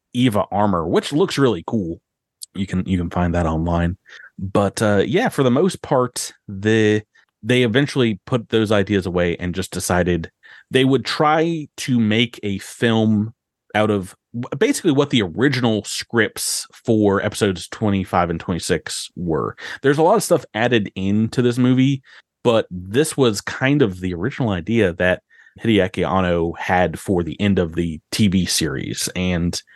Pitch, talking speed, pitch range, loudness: 105 Hz, 160 wpm, 90-125 Hz, -19 LUFS